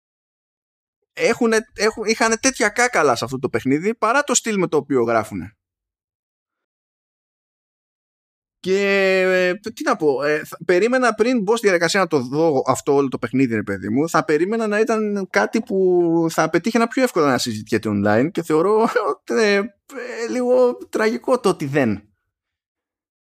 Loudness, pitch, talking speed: -19 LUFS, 185 Hz, 155 wpm